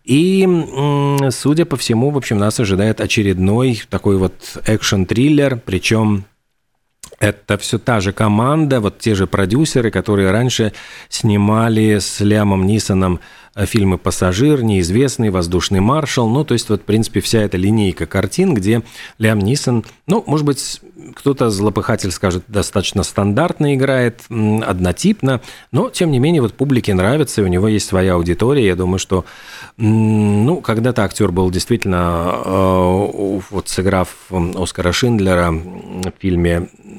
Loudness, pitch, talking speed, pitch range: -15 LUFS, 105 Hz, 135 wpm, 95-125 Hz